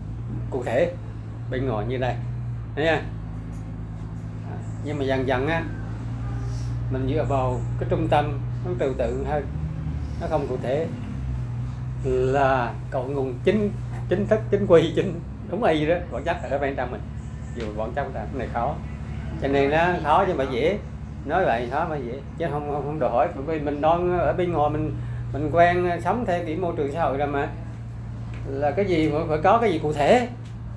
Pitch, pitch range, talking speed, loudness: 125 Hz, 120-145 Hz, 195 wpm, -25 LUFS